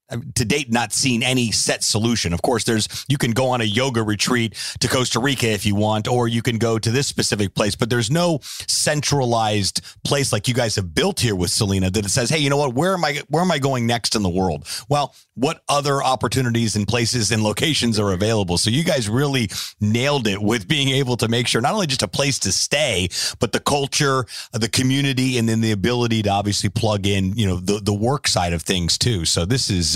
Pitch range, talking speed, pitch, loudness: 105-135 Hz, 230 wpm, 120 Hz, -19 LUFS